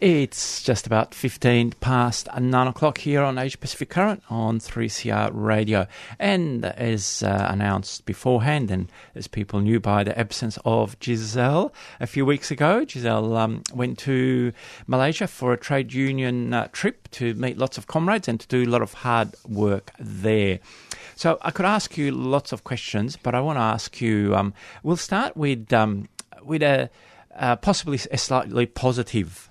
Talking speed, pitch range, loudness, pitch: 170 wpm, 110-135 Hz, -23 LUFS, 120 Hz